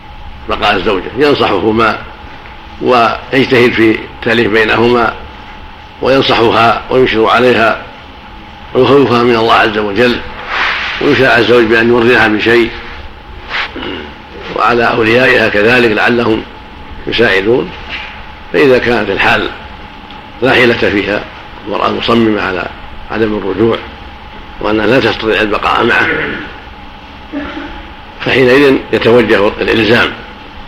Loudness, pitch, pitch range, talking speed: -10 LUFS, 115 Hz, 110-125 Hz, 85 wpm